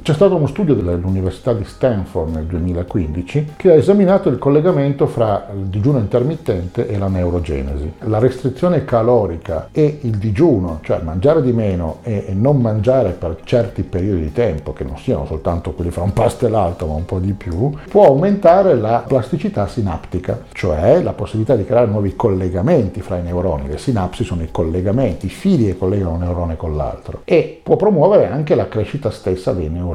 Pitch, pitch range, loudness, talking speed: 105 Hz, 90-130 Hz, -16 LUFS, 180 wpm